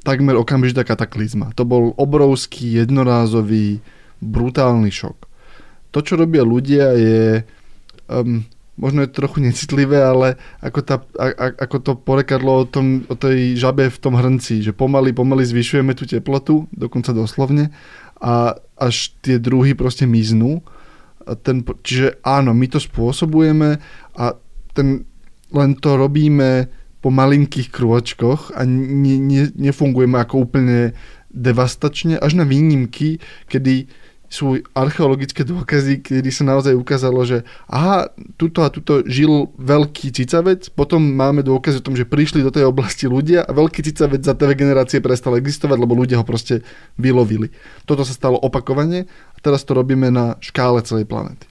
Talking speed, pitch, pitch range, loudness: 150 wpm, 130 Hz, 125-145 Hz, -16 LUFS